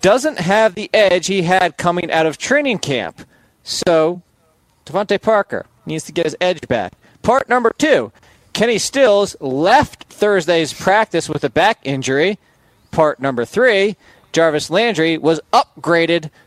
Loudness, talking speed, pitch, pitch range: -16 LUFS, 140 wpm, 170 Hz, 155-200 Hz